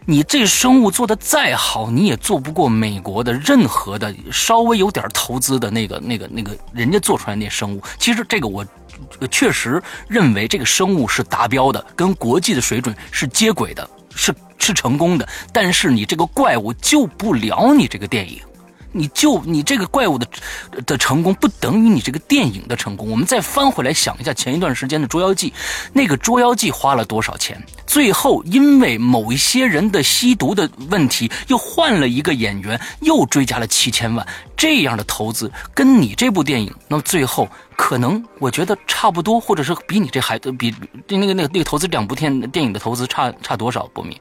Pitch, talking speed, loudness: 150 Hz, 300 characters per minute, -16 LUFS